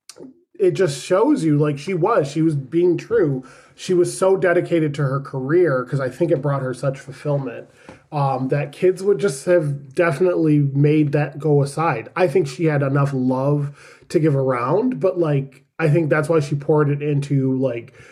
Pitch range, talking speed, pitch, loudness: 140-175 Hz, 190 wpm, 150 Hz, -19 LUFS